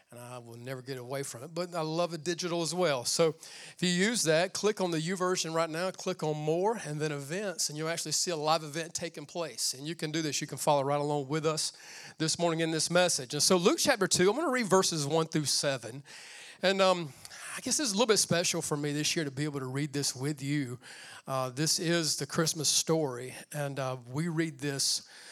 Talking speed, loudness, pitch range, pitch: 250 wpm, -30 LUFS, 145-175 Hz, 160 Hz